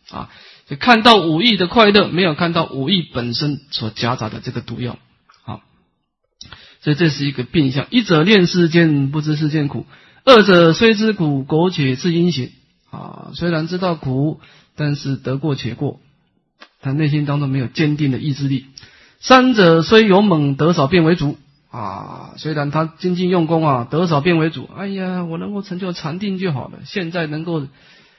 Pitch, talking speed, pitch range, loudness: 160 Hz, 255 characters per minute, 140-180 Hz, -16 LUFS